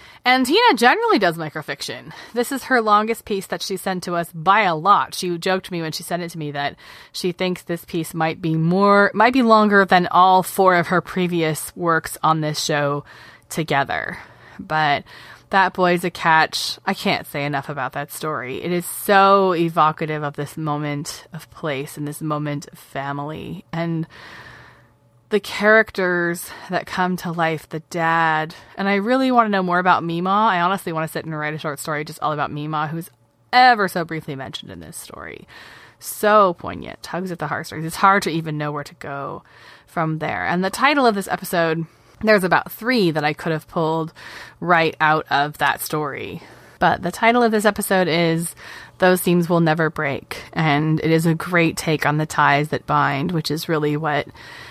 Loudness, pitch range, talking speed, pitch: -19 LUFS, 155-190 Hz, 195 wpm, 165 Hz